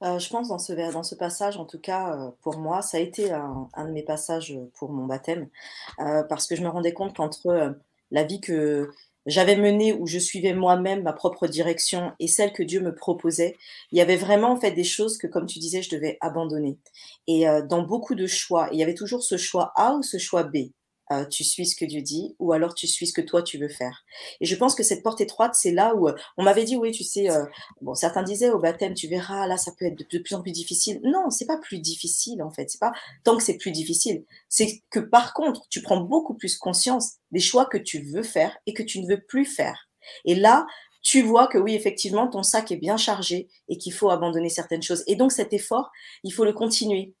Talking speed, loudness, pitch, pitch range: 250 wpm, -24 LUFS, 180 Hz, 165-210 Hz